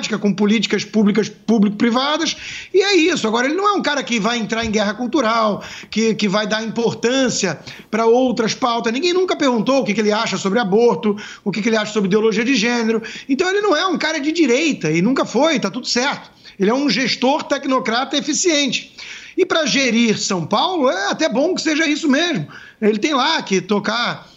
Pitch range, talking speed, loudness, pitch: 215-290 Hz, 205 wpm, -17 LUFS, 235 Hz